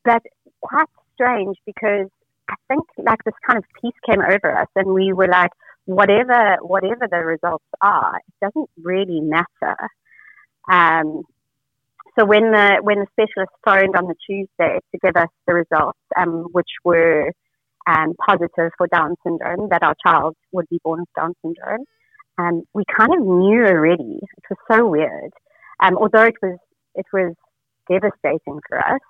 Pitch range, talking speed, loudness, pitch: 170-215 Hz, 165 wpm, -17 LUFS, 185 Hz